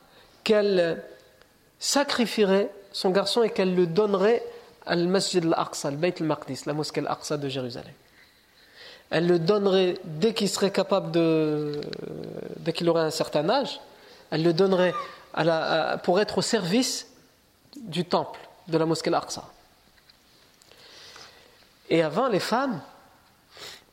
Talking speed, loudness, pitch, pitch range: 130 wpm, -25 LUFS, 190 Hz, 165-215 Hz